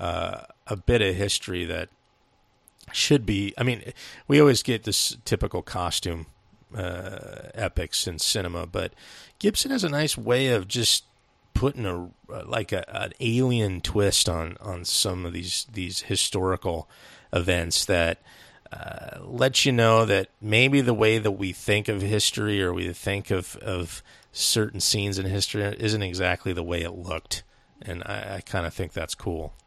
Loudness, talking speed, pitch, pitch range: -25 LUFS, 160 wpm, 100 Hz, 90-115 Hz